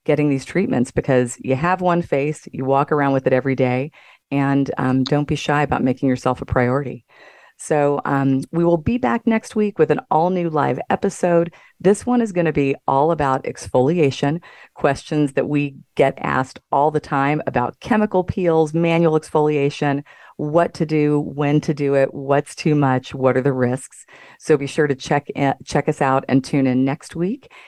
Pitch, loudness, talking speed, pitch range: 145 Hz, -19 LUFS, 195 wpm, 135-165 Hz